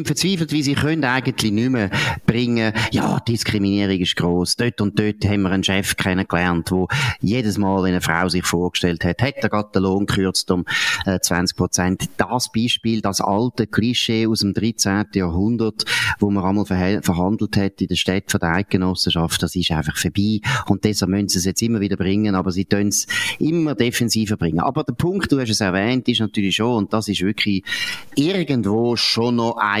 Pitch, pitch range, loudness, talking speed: 100 Hz, 95-115 Hz, -19 LUFS, 190 wpm